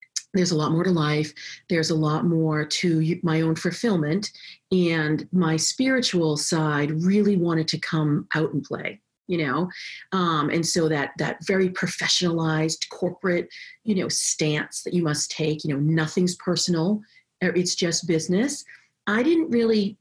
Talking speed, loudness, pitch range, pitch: 155 wpm, -23 LUFS, 160-185 Hz, 170 Hz